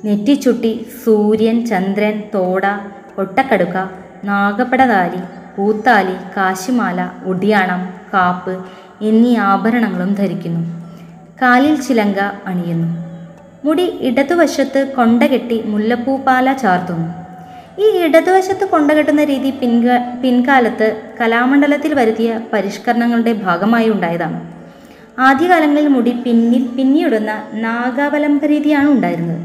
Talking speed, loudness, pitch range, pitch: 75 wpm, -14 LUFS, 190-260 Hz, 225 Hz